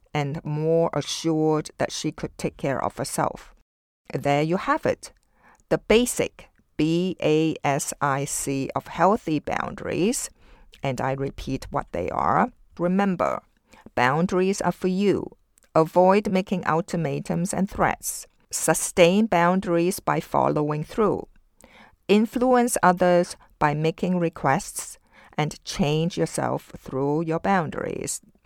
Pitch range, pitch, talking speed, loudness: 150-185 Hz, 165 Hz, 110 wpm, -24 LUFS